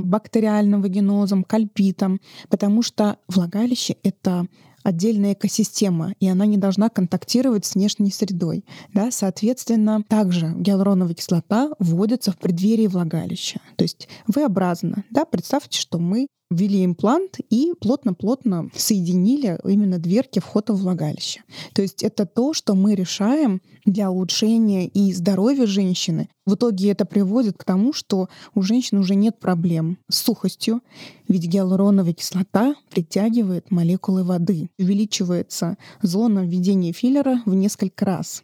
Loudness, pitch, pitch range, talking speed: -20 LUFS, 200 Hz, 185-220 Hz, 130 wpm